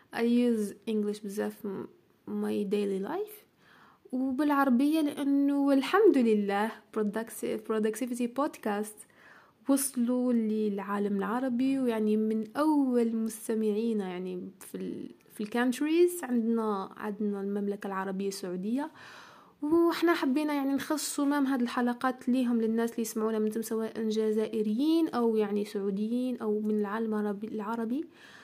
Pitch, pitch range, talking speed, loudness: 225 Hz, 210-270 Hz, 110 wpm, -30 LUFS